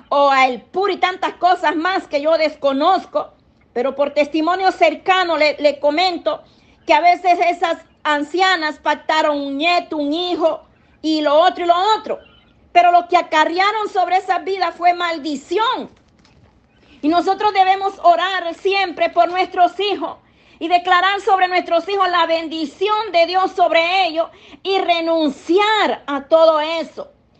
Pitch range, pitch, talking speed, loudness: 310-370 Hz, 345 Hz, 145 wpm, -17 LUFS